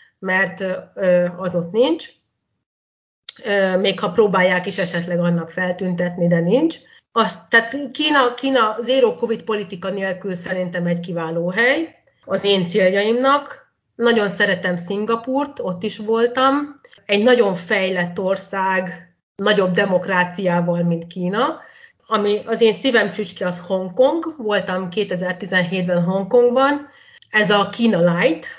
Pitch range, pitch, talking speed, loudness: 180-230 Hz, 195 Hz, 120 wpm, -19 LUFS